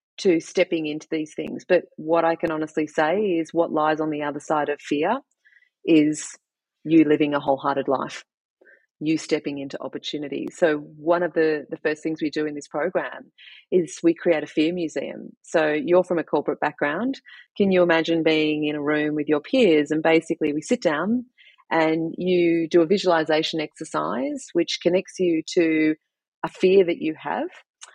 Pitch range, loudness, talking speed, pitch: 150-175 Hz, -23 LUFS, 180 wpm, 160 Hz